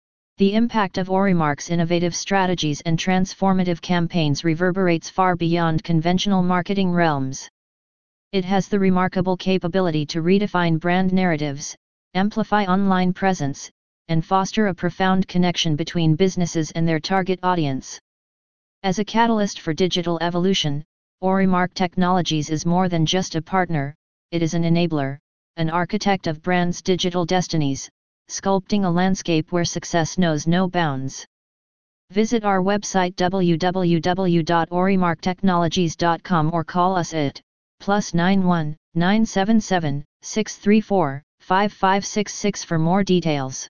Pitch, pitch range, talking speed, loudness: 180 Hz, 165-190 Hz, 115 wpm, -21 LUFS